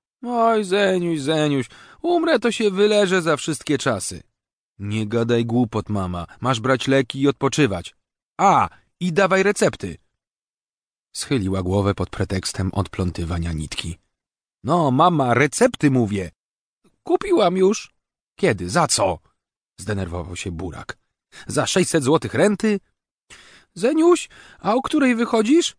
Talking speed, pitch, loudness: 115 wpm, 140 Hz, -20 LUFS